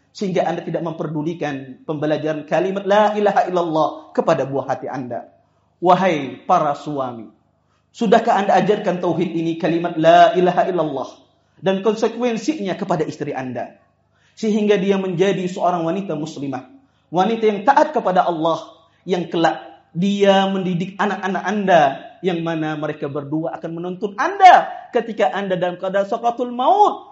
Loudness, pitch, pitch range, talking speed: -19 LUFS, 180 Hz, 160-205 Hz, 135 wpm